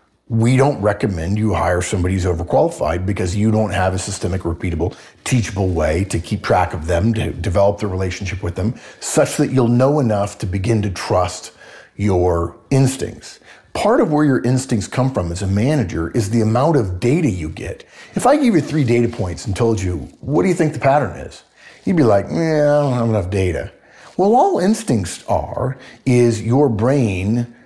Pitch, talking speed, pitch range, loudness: 110 Hz, 195 wpm, 95-125 Hz, -18 LUFS